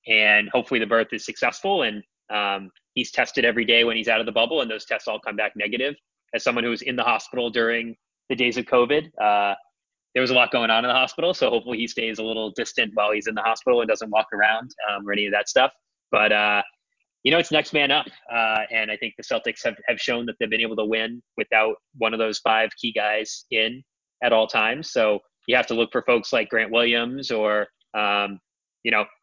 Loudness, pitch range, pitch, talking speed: -22 LUFS, 105-120 Hz, 110 Hz, 240 wpm